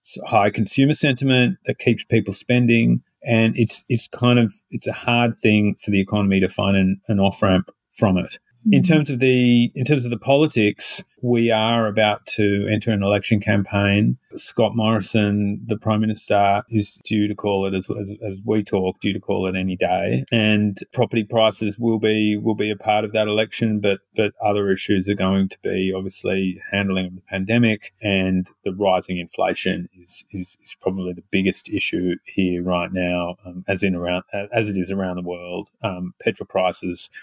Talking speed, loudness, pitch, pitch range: 185 wpm, -20 LUFS, 105 Hz, 95-110 Hz